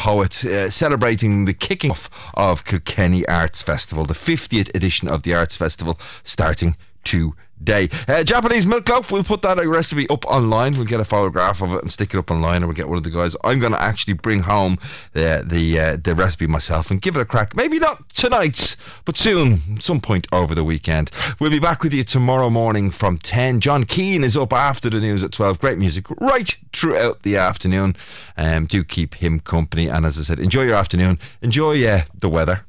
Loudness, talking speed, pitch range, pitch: -18 LUFS, 210 wpm, 85-130 Hz, 100 Hz